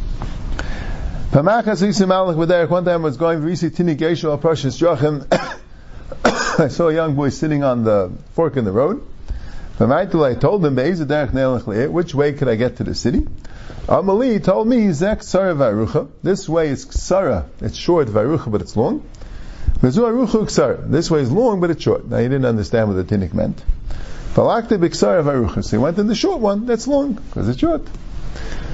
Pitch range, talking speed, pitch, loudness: 135-190 Hz, 140 wpm, 165 Hz, -18 LUFS